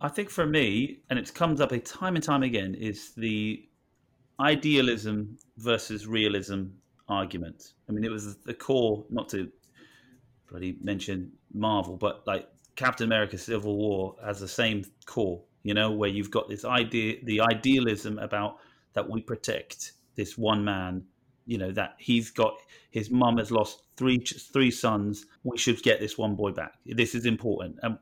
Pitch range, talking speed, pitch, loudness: 105-125 Hz, 170 wpm, 110 Hz, -28 LUFS